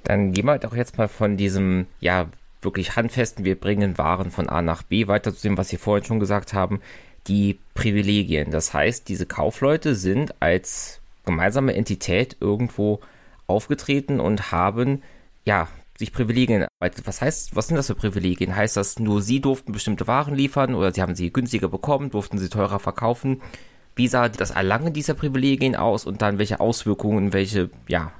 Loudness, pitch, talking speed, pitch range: -23 LUFS, 105 Hz, 180 wpm, 95-120 Hz